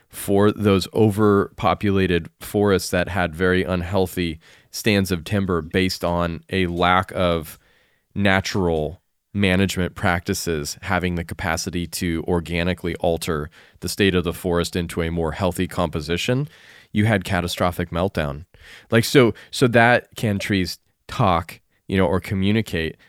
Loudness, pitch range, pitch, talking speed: -21 LUFS, 85-100 Hz, 90 Hz, 130 wpm